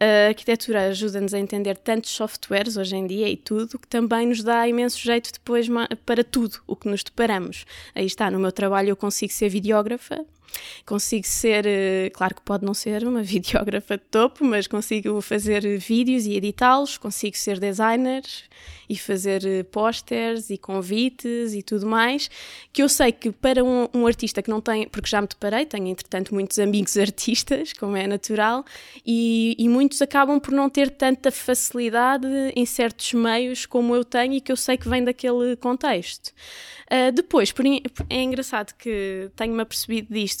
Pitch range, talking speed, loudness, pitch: 205-245 Hz, 175 wpm, -22 LUFS, 225 Hz